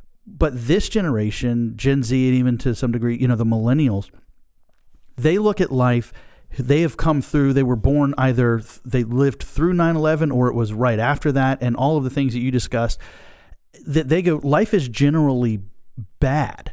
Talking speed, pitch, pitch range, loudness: 185 wpm, 130 Hz, 120-145 Hz, -20 LUFS